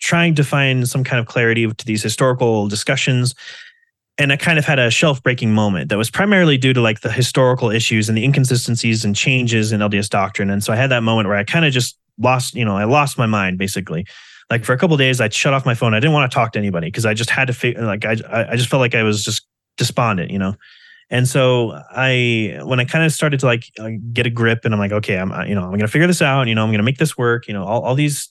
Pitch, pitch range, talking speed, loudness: 120 Hz, 110-135 Hz, 280 wpm, -16 LUFS